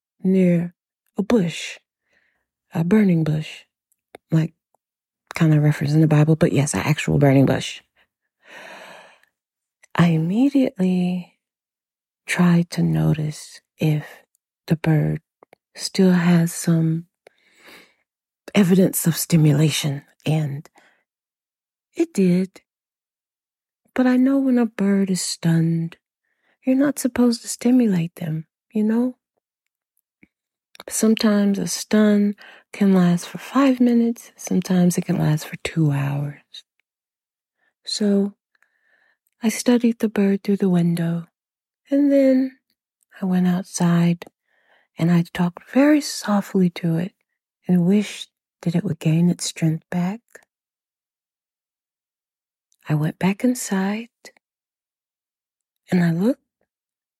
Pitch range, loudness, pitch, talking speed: 165-220 Hz, -20 LUFS, 180 Hz, 110 wpm